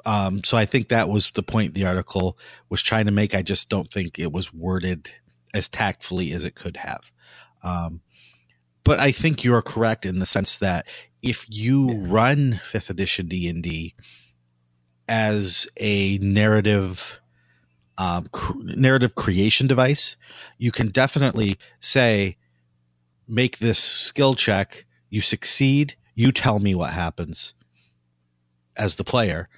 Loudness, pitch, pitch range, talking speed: -22 LUFS, 100 Hz, 85-115 Hz, 145 wpm